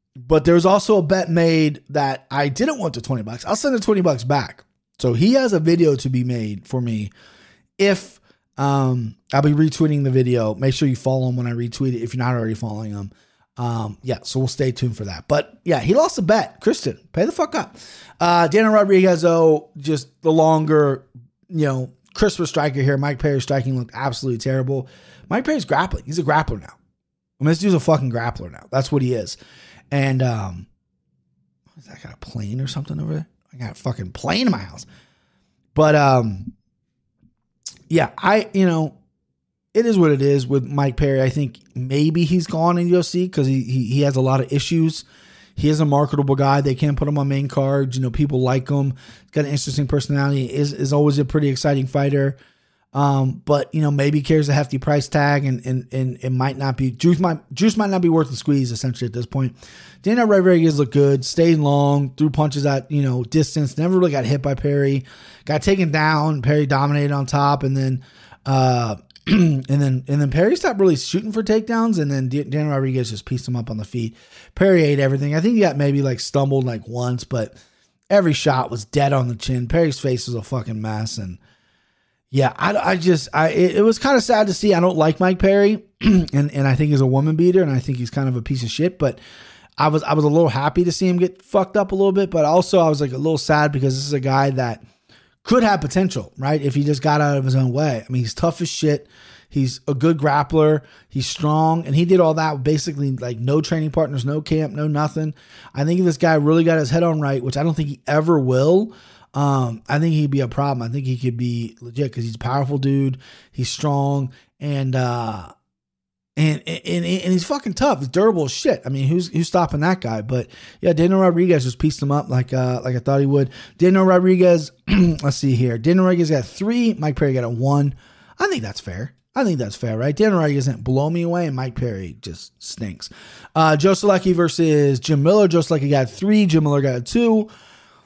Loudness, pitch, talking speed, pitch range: -19 LUFS, 145 Hz, 225 wpm, 130-165 Hz